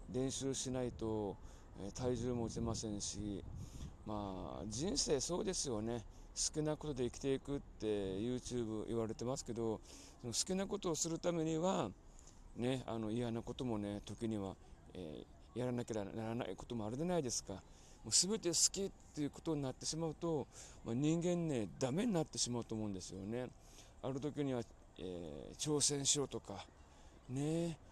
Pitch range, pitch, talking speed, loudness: 100-145 Hz, 120 Hz, 325 characters per minute, -40 LUFS